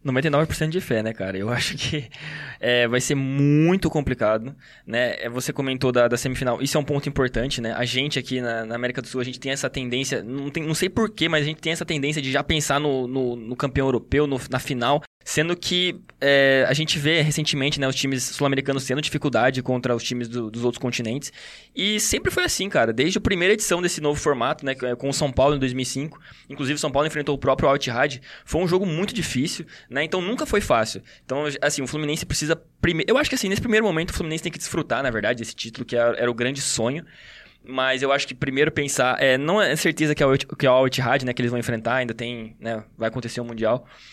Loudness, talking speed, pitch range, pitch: -23 LUFS, 235 wpm, 125-155 Hz, 140 Hz